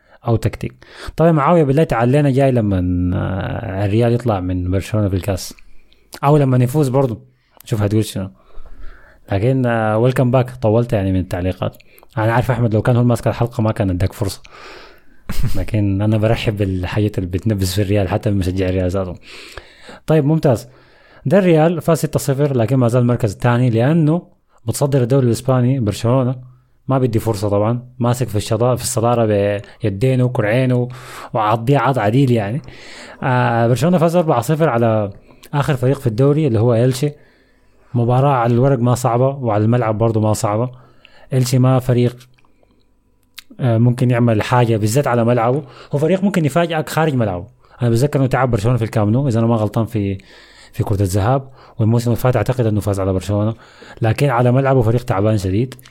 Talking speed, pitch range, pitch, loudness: 160 wpm, 110-130 Hz, 120 Hz, -17 LUFS